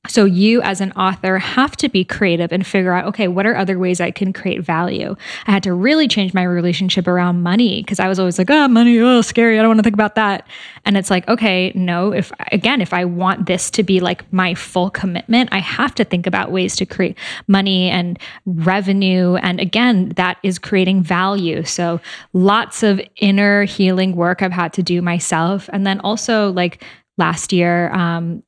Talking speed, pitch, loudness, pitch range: 210 wpm, 190 Hz, -16 LUFS, 180-205 Hz